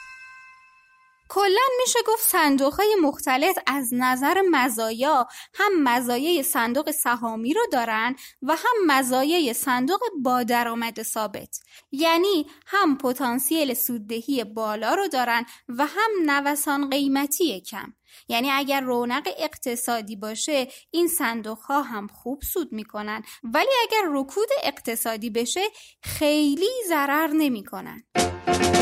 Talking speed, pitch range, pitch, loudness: 110 wpm, 240-320 Hz, 270 Hz, -23 LUFS